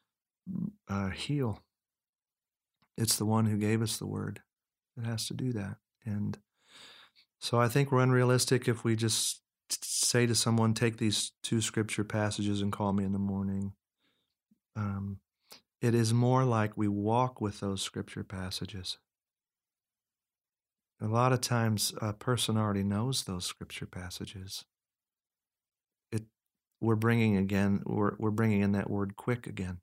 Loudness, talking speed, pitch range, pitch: -31 LUFS, 145 wpm, 100-115 Hz, 110 Hz